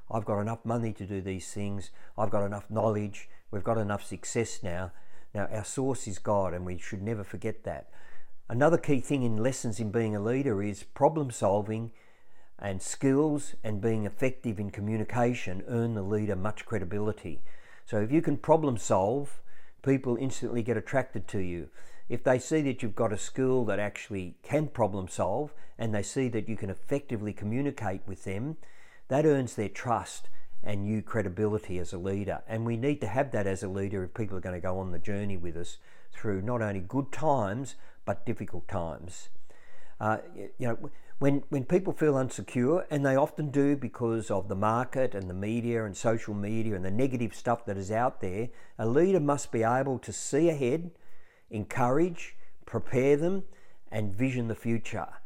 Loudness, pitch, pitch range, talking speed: -31 LUFS, 110 Hz, 100-130 Hz, 185 wpm